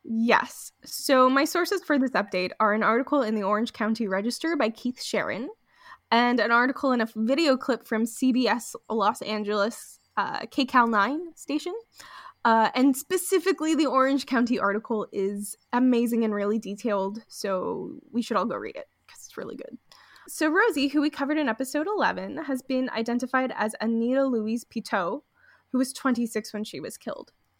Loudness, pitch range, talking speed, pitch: -26 LUFS, 220-285 Hz, 170 wpm, 245 Hz